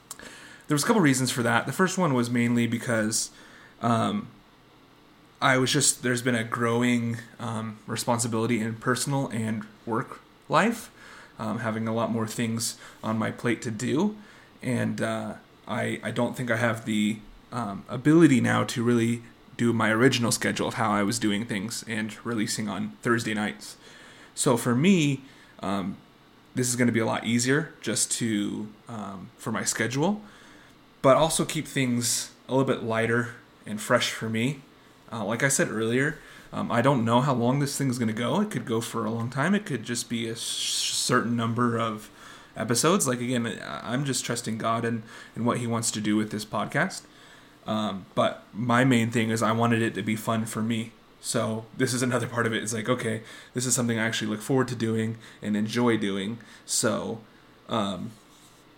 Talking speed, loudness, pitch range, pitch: 190 wpm, -26 LUFS, 110-125 Hz, 115 Hz